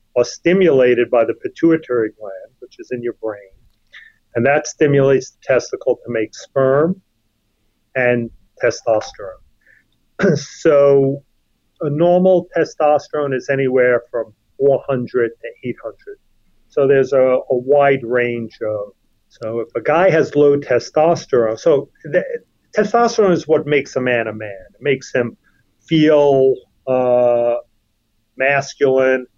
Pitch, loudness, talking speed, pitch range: 130 Hz, -16 LUFS, 125 wpm, 120-150 Hz